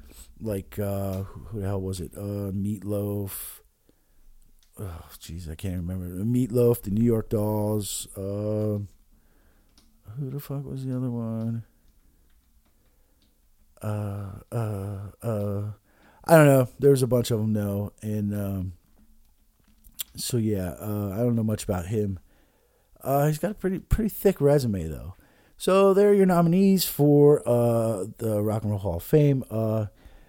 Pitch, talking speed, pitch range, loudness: 105 Hz, 150 wpm, 95-120 Hz, -25 LUFS